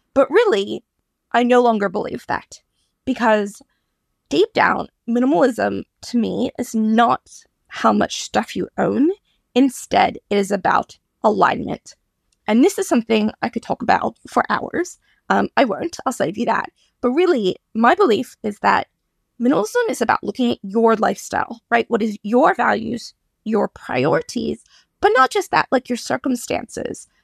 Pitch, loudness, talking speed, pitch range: 245 Hz, -19 LUFS, 150 wpm, 225-285 Hz